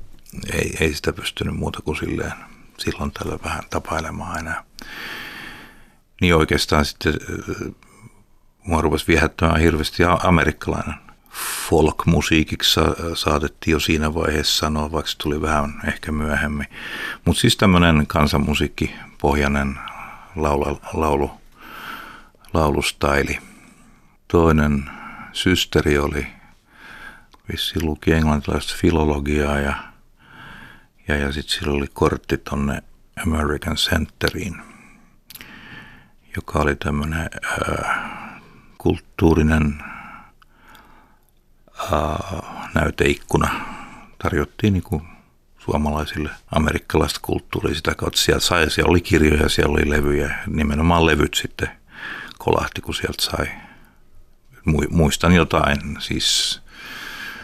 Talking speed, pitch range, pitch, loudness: 90 wpm, 75-80 Hz, 75 Hz, -20 LUFS